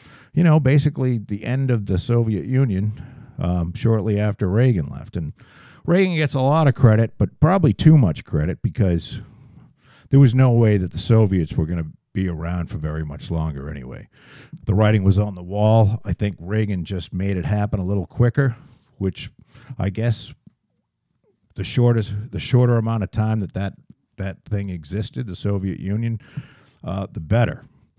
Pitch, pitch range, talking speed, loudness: 110 Hz, 95-130 Hz, 175 wpm, -20 LUFS